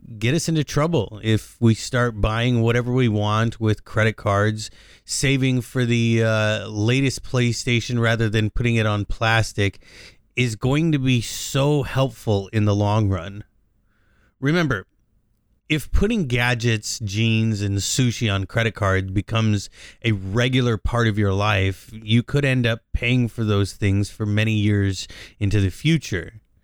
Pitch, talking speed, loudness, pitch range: 110 Hz, 150 wpm, -21 LUFS, 105-120 Hz